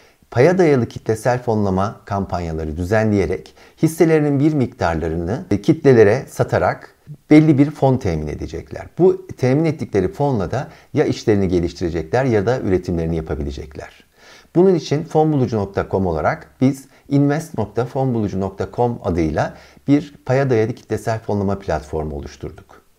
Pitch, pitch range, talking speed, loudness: 115 Hz, 90-140 Hz, 110 wpm, -18 LUFS